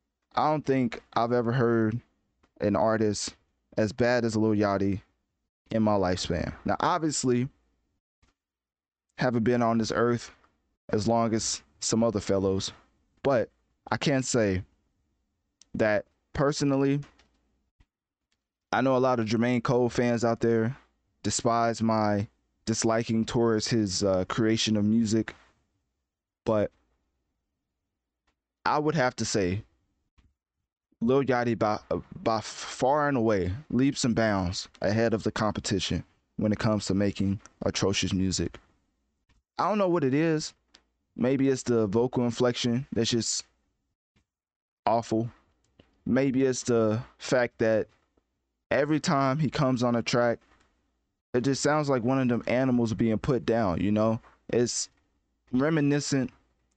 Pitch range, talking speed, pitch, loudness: 100-125 Hz, 130 wpm, 115 Hz, -27 LUFS